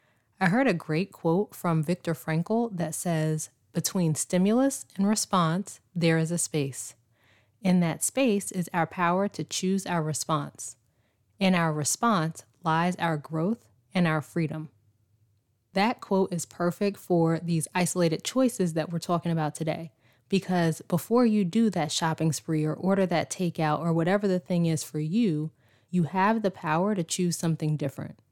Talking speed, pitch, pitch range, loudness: 160 wpm, 165 Hz, 155-185 Hz, -27 LUFS